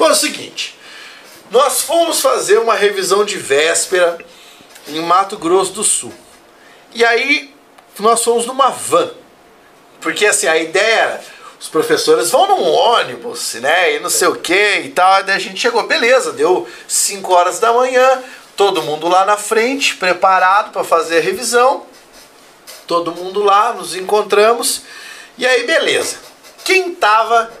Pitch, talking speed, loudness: 235 Hz, 150 wpm, -13 LUFS